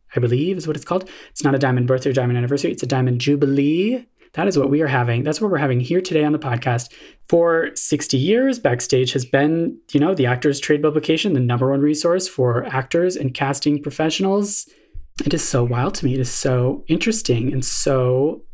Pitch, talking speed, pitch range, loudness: 140 Hz, 215 wpm, 130-165 Hz, -19 LUFS